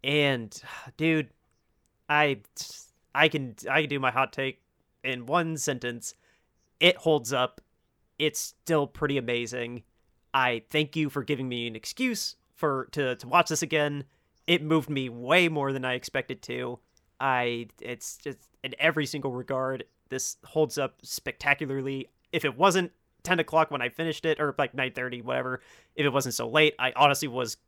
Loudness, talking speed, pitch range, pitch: -27 LUFS, 165 wpm, 125-155 Hz, 135 Hz